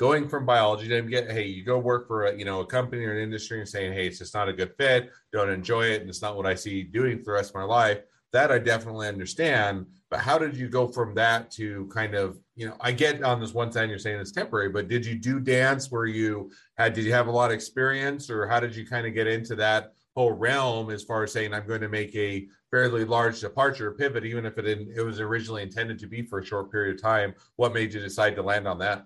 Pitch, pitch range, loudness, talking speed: 110 Hz, 105-120 Hz, -26 LUFS, 275 wpm